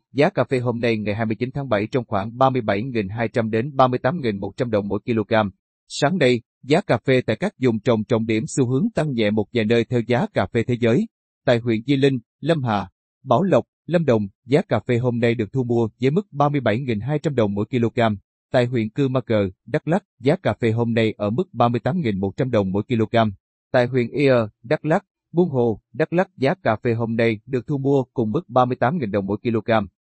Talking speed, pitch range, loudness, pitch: 210 wpm, 110-135 Hz, -21 LUFS, 120 Hz